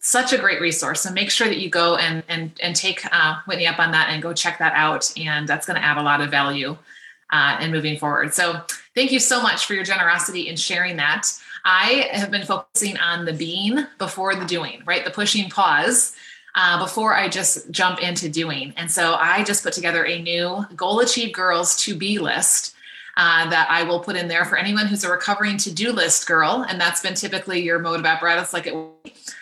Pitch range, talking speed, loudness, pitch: 165-200 Hz, 225 wpm, -19 LUFS, 175 Hz